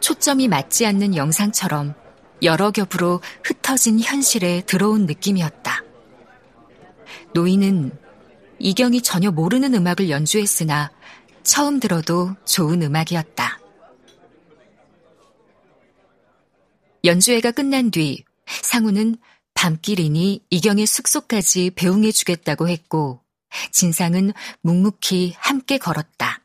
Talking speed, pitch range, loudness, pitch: 230 characters per minute, 170-220 Hz, -18 LUFS, 190 Hz